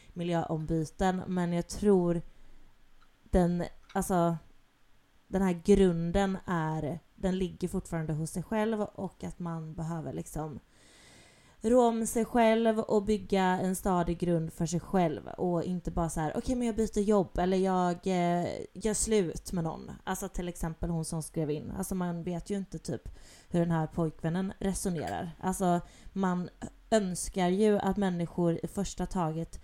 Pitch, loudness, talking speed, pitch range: 180 Hz, -31 LUFS, 160 wpm, 165-195 Hz